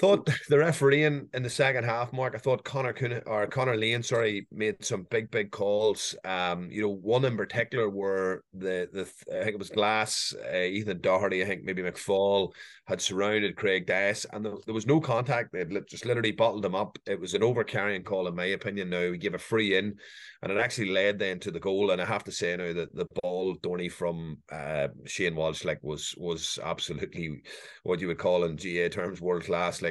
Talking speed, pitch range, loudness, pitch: 220 wpm, 90-120 Hz, -29 LUFS, 100 Hz